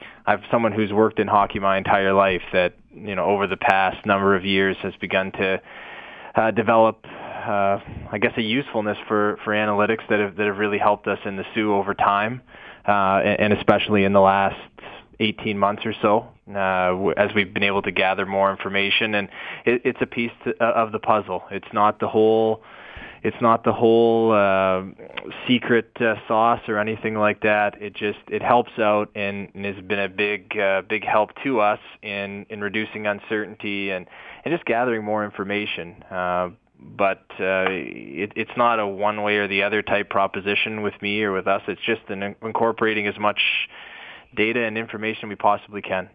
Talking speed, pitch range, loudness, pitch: 185 wpm, 100-110 Hz, -21 LUFS, 105 Hz